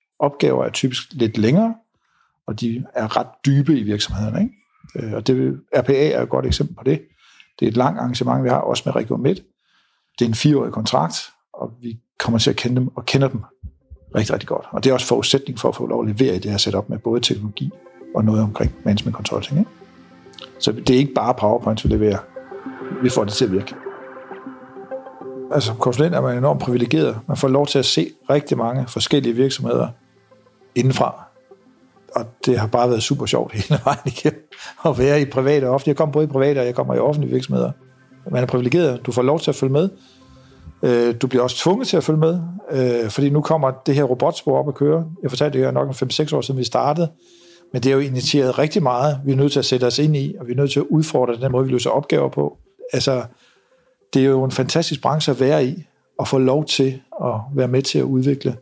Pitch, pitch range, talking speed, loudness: 130 Hz, 120-145 Hz, 225 wpm, -19 LUFS